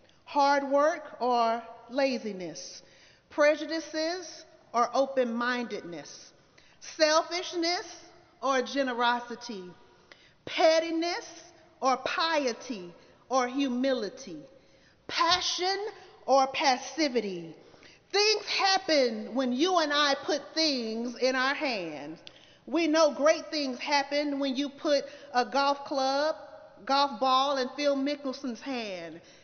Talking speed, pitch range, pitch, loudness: 95 wpm, 250-320 Hz, 280 Hz, -28 LUFS